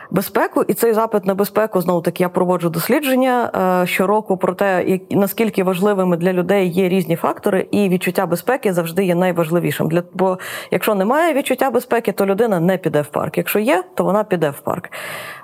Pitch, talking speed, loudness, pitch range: 190 Hz, 180 wpm, -17 LUFS, 180-215 Hz